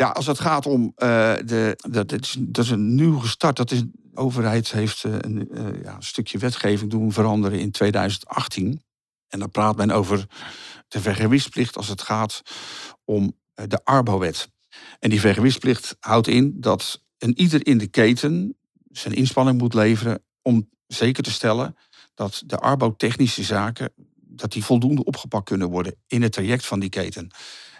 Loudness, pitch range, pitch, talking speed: -22 LUFS, 105-125 Hz, 115 Hz, 175 wpm